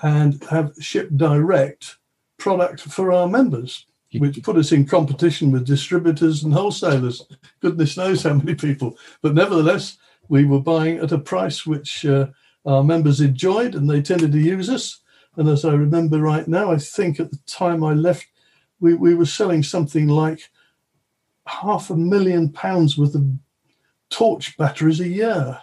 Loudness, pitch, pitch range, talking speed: -19 LUFS, 160 Hz, 145-175 Hz, 165 wpm